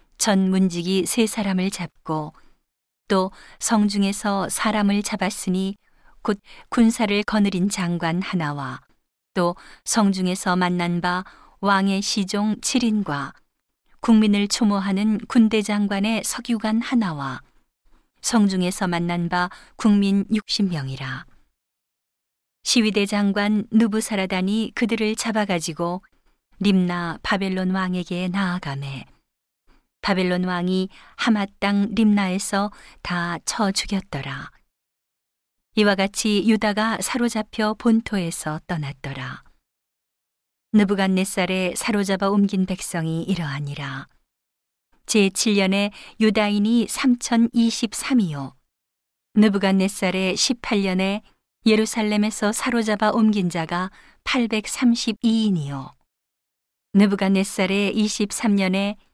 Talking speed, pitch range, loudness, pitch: 210 characters per minute, 180-215 Hz, -22 LUFS, 200 Hz